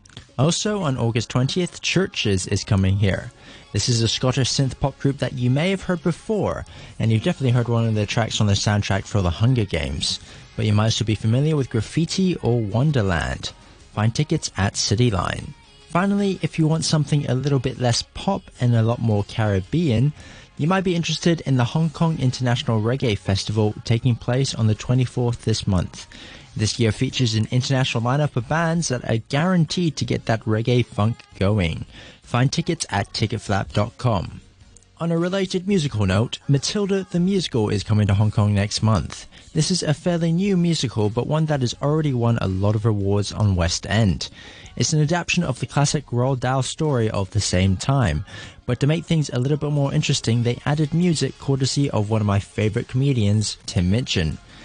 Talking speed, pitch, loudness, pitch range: 190 wpm, 120 Hz, -21 LUFS, 105-150 Hz